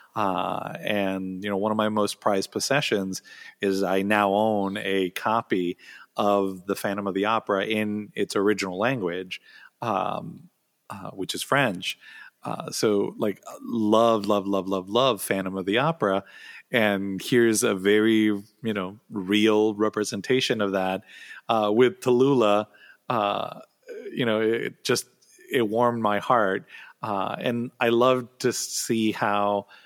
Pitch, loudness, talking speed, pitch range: 105 Hz, -25 LUFS, 145 wpm, 100-110 Hz